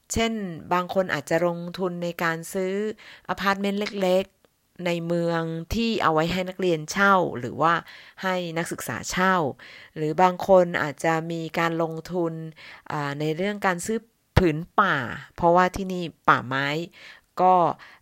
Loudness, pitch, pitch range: -24 LUFS, 175 Hz, 165-185 Hz